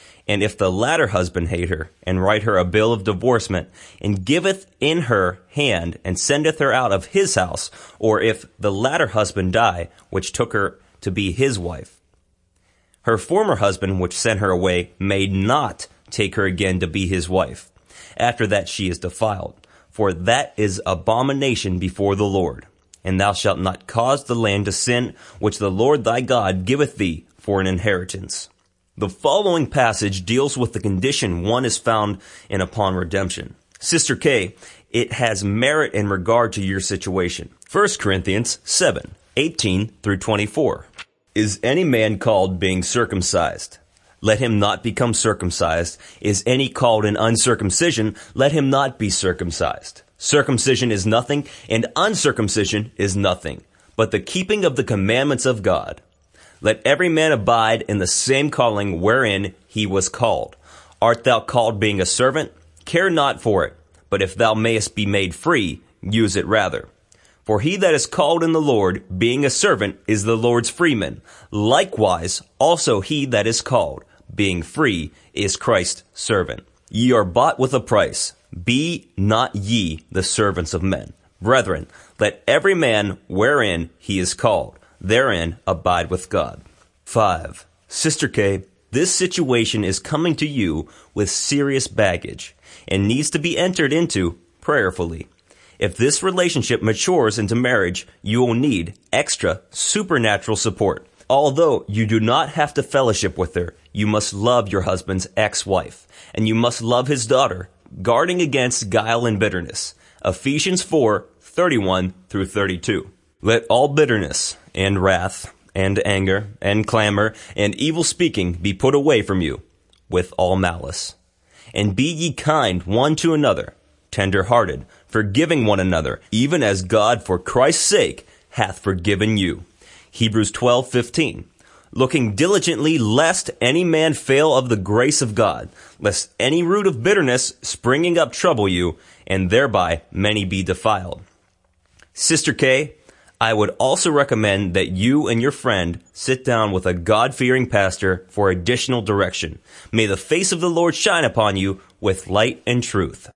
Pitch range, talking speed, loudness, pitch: 95-125 Hz, 155 wpm, -19 LUFS, 105 Hz